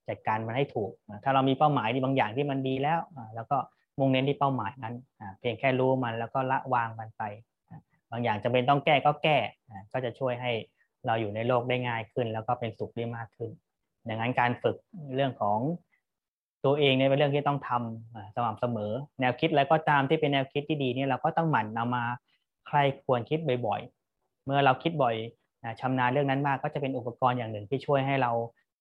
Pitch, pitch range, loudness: 130 Hz, 115-140 Hz, -29 LUFS